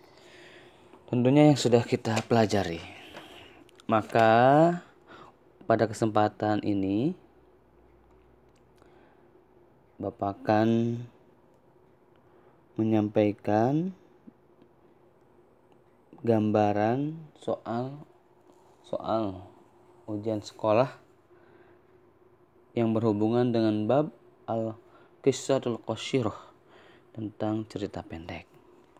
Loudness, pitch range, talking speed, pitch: -27 LUFS, 105-130 Hz, 50 wpm, 115 Hz